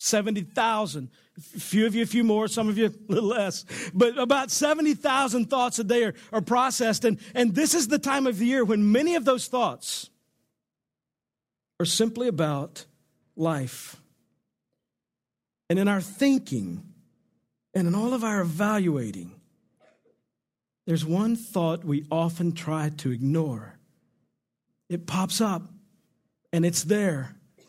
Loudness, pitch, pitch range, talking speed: -25 LUFS, 210 Hz, 165-240 Hz, 145 wpm